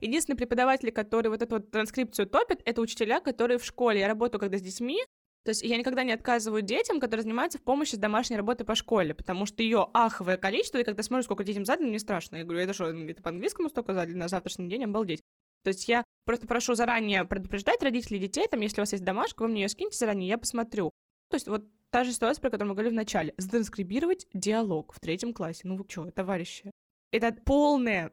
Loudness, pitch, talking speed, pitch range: -29 LUFS, 225 Hz, 220 wpm, 200-245 Hz